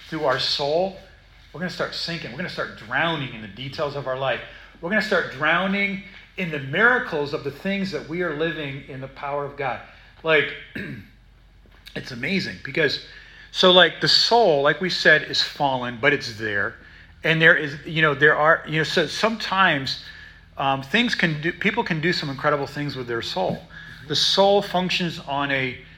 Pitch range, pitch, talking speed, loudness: 135-180 Hz, 155 Hz, 195 wpm, -21 LUFS